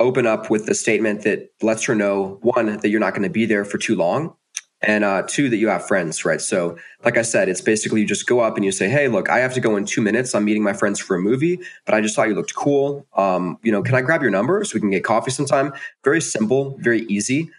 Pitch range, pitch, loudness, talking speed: 100-130 Hz, 105 Hz, -19 LUFS, 280 wpm